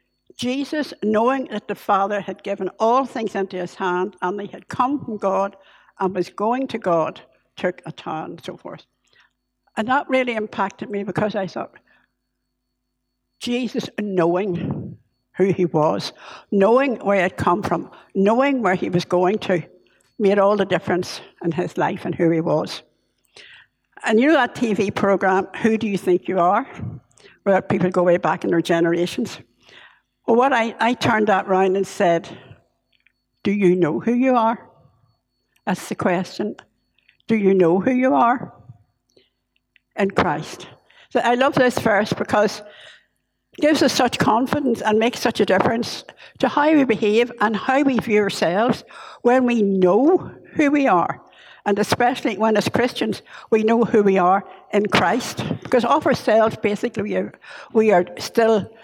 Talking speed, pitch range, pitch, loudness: 165 wpm, 180-235 Hz, 205 Hz, -20 LUFS